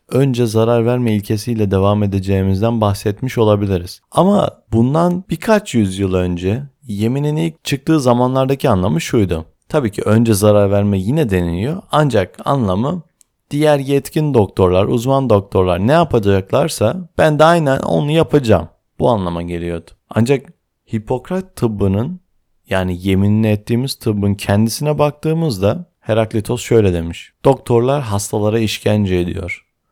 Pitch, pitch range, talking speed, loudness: 115 Hz, 100-140 Hz, 120 wpm, -16 LUFS